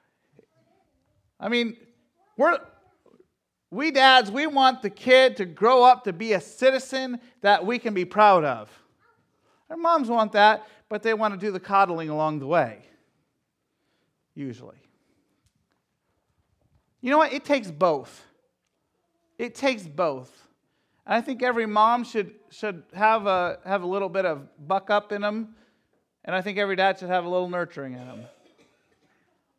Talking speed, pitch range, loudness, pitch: 155 wpm, 185-250 Hz, -23 LUFS, 210 Hz